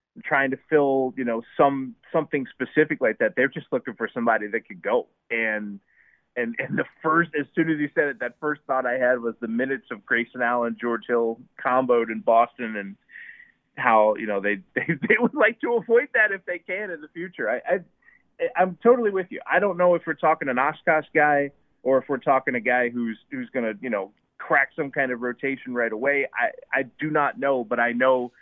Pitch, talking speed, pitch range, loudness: 135 Hz, 220 wpm, 120-160 Hz, -24 LUFS